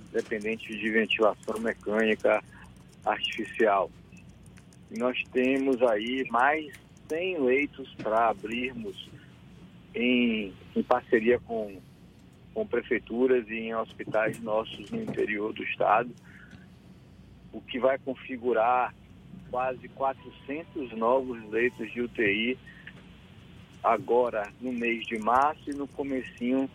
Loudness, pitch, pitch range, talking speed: -28 LUFS, 120 Hz, 110-130 Hz, 105 wpm